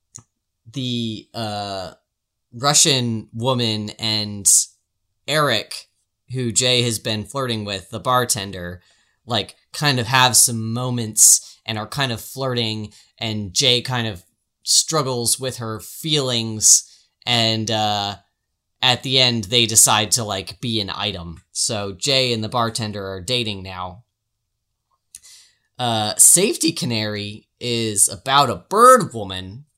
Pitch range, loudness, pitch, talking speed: 105-125 Hz, -17 LUFS, 110 Hz, 125 wpm